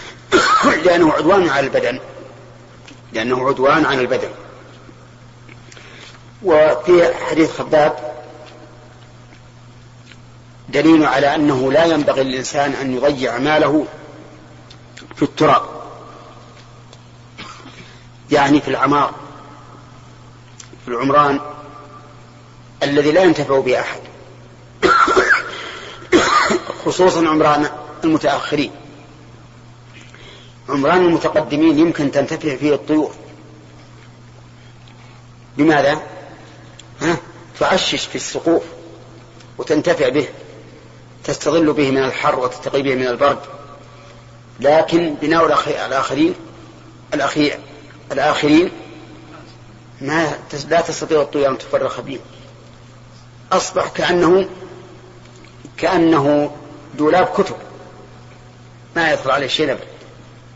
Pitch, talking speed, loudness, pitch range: 135 Hz, 75 wpm, -16 LUFS, 120-150 Hz